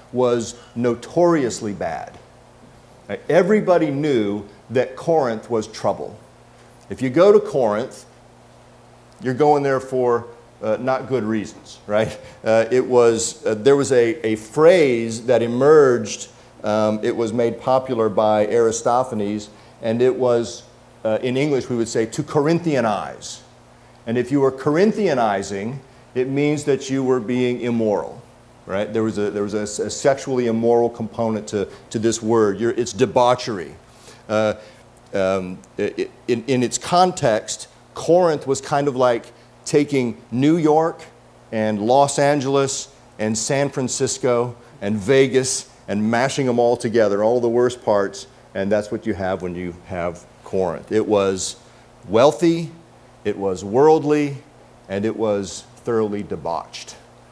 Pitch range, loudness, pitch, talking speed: 110-135 Hz, -20 LUFS, 120 Hz, 140 wpm